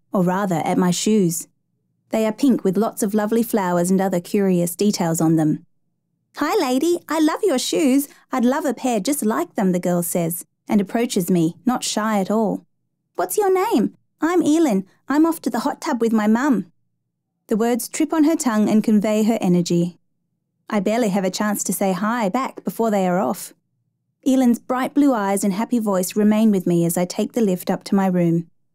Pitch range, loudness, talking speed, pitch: 180-250 Hz, -20 LUFS, 205 wpm, 210 Hz